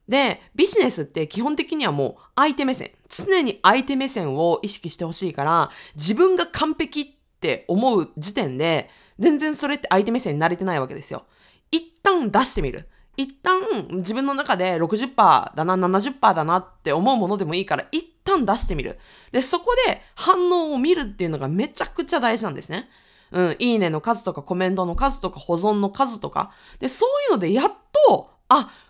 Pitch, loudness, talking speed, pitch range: 235 Hz, -21 LUFS, 345 characters per minute, 185-305 Hz